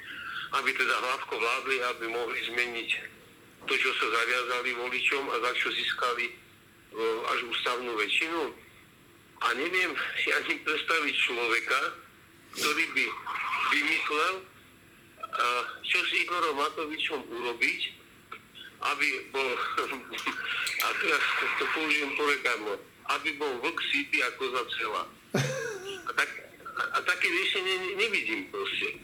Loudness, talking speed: -28 LUFS, 110 wpm